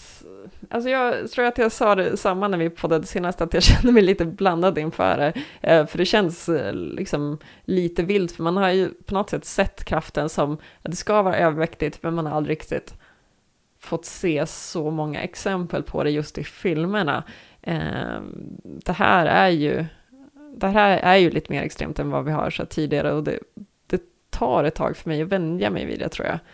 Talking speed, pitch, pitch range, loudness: 200 wpm, 175 Hz, 160-195 Hz, -22 LUFS